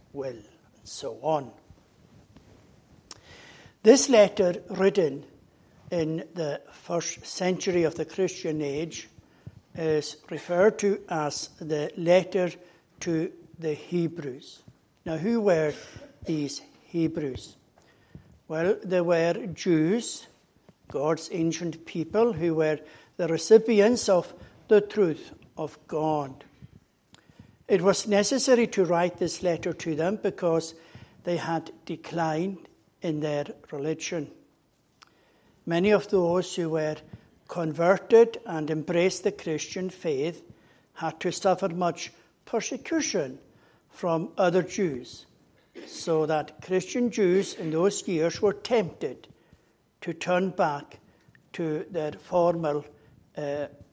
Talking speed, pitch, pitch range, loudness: 105 wpm, 170 Hz, 155-185 Hz, -27 LUFS